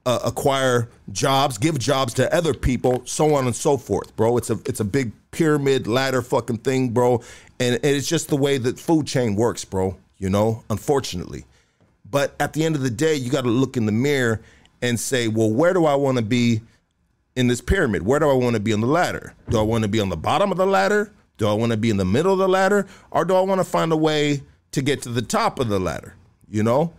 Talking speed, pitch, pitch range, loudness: 250 wpm, 125 Hz, 110-145 Hz, -21 LUFS